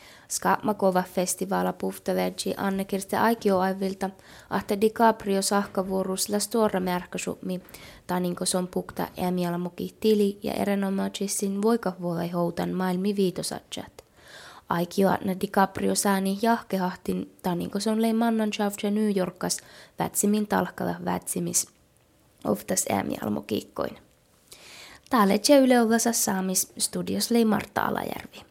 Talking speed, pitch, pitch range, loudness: 85 wpm, 195 Hz, 185-210 Hz, -26 LUFS